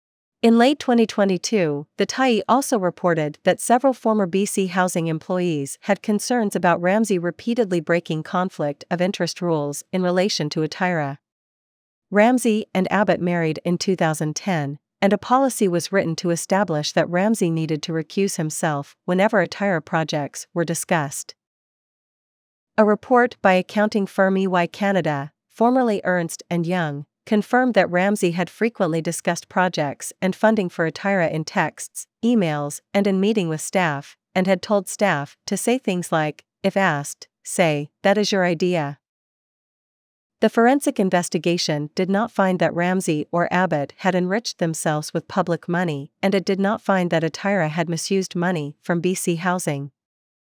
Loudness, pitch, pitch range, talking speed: -21 LUFS, 180 Hz, 160-200 Hz, 150 wpm